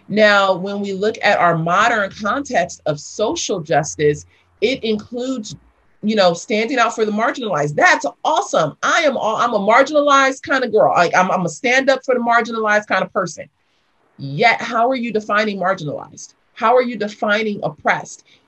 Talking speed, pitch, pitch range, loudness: 170 wpm, 210 Hz, 180-235 Hz, -17 LUFS